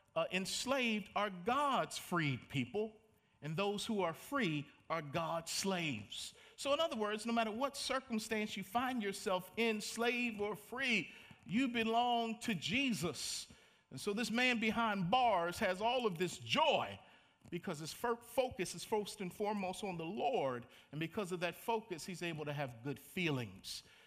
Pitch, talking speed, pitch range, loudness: 200 Hz, 160 wpm, 165-230 Hz, -38 LUFS